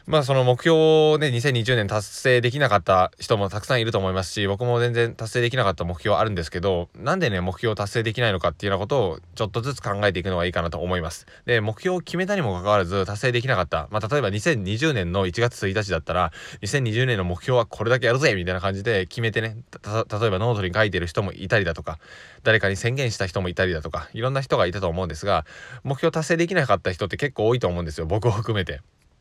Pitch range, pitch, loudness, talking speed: 95-125 Hz, 110 Hz, -23 LUFS, 485 characters per minute